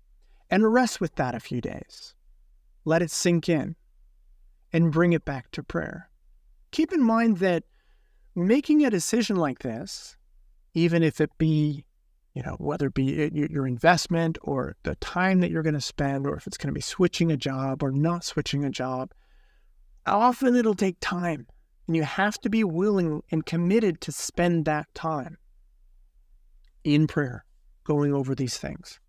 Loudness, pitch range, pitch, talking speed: -25 LUFS, 140-185 Hz, 160 Hz, 165 wpm